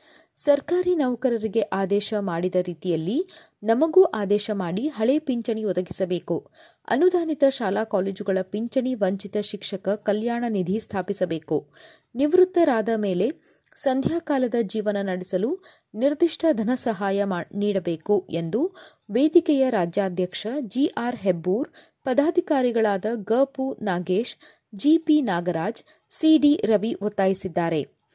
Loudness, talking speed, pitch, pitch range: -24 LUFS, 90 wpm, 220 Hz, 195-275 Hz